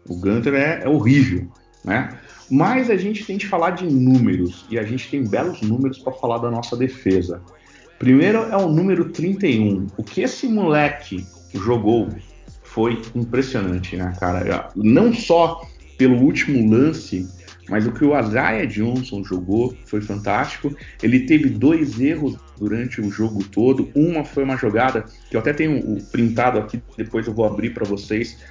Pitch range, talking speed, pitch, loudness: 100-145 Hz, 160 wpm, 115 Hz, -19 LUFS